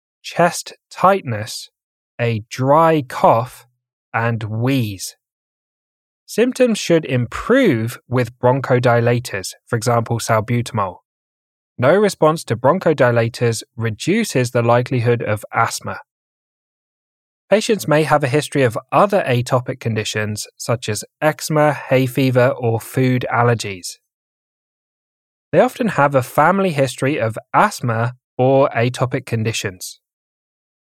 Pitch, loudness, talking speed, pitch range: 125 Hz, -17 LUFS, 100 wpm, 115-145 Hz